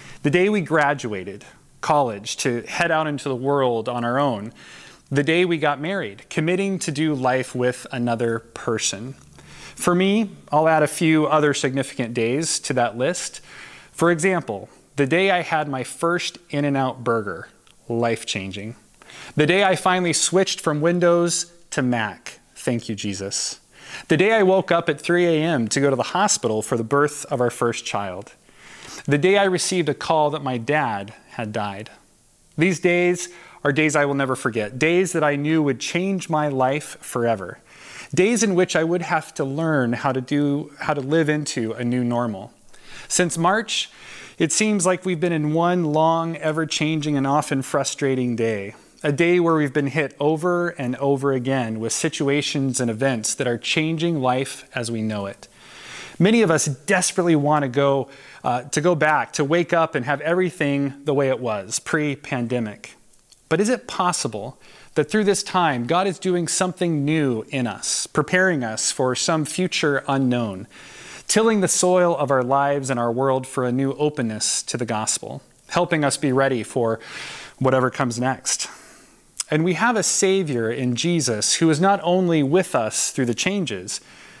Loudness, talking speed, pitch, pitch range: -21 LUFS, 180 wpm, 145 Hz, 125-170 Hz